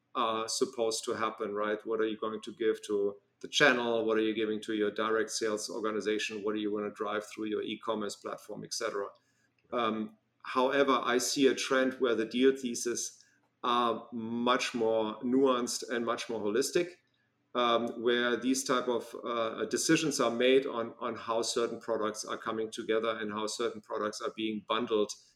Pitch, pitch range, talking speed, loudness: 115 Hz, 110-125 Hz, 180 wpm, -31 LUFS